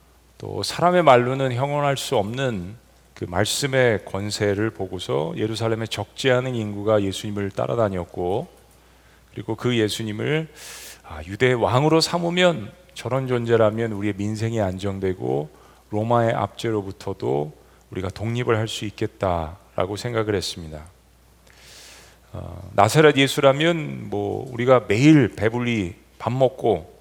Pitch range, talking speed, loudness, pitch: 100-125 Hz, 280 characters per minute, -22 LUFS, 110 Hz